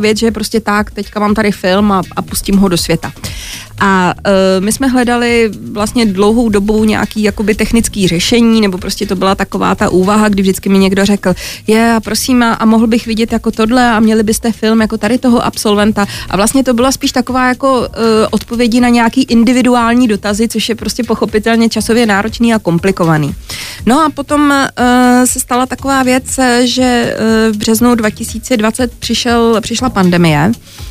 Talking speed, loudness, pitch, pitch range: 175 wpm, -11 LUFS, 220 Hz, 205-240 Hz